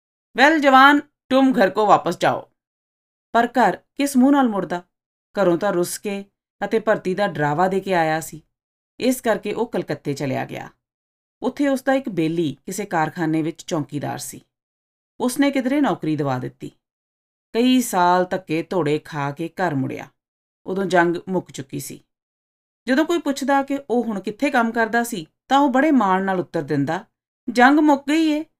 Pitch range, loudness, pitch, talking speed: 160-255 Hz, -20 LUFS, 195 Hz, 170 wpm